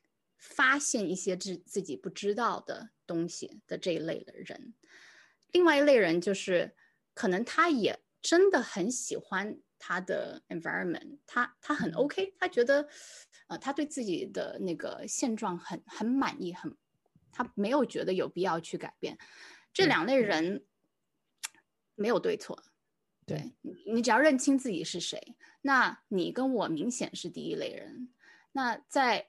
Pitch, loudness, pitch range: 260 Hz, -31 LUFS, 210-305 Hz